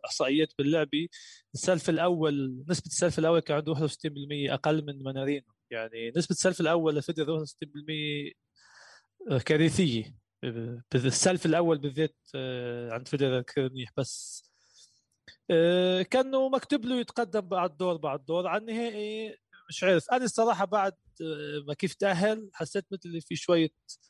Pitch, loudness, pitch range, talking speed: 160 Hz, -29 LUFS, 140-185 Hz, 120 wpm